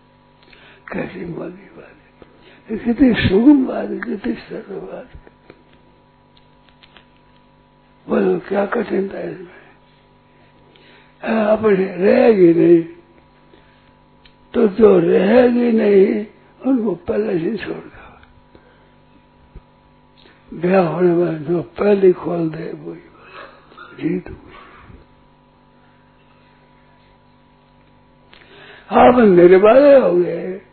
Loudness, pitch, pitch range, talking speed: -15 LUFS, 195 Hz, 175-225 Hz, 70 wpm